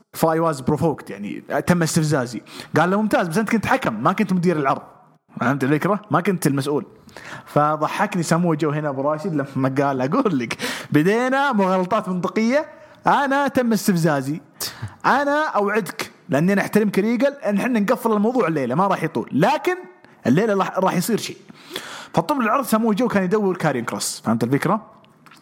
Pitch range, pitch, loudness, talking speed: 155-220 Hz, 190 Hz, -20 LUFS, 155 wpm